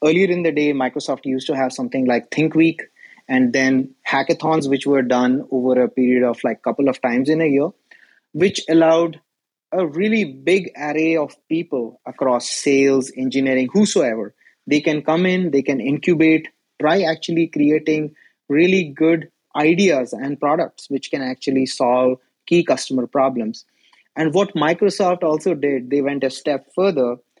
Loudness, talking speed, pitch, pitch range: -18 LUFS, 160 wpm, 145 Hz, 130-165 Hz